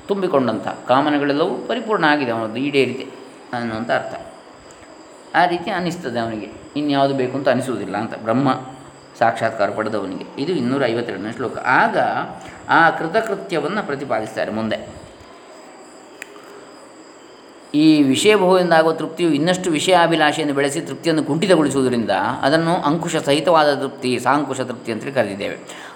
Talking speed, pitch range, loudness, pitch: 105 wpm, 135-180 Hz, -19 LUFS, 150 Hz